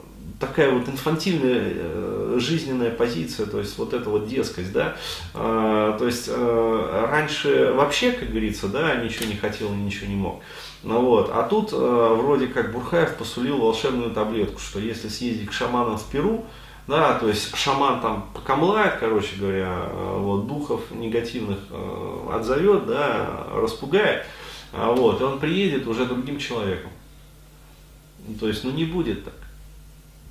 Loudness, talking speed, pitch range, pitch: -23 LUFS, 135 wpm, 105-130 Hz, 115 Hz